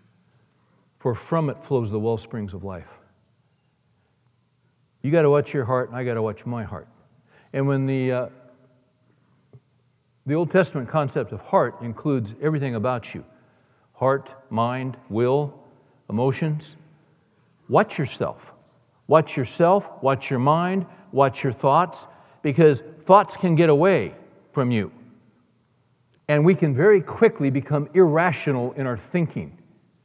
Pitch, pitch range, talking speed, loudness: 135 Hz, 125-155 Hz, 130 wpm, -22 LUFS